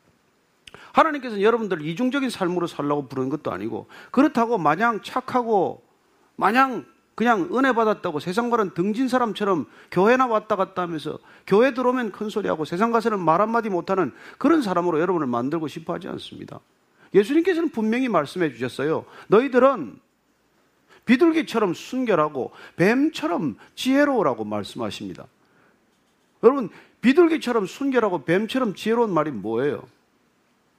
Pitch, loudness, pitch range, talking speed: 230 Hz, -22 LUFS, 185-260 Hz, 350 characters per minute